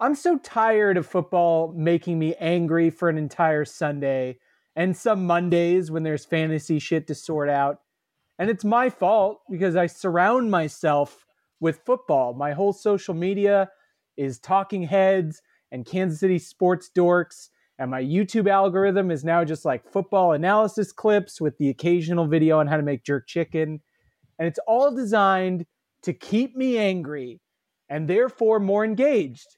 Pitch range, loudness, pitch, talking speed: 155-200 Hz, -23 LUFS, 175 Hz, 155 wpm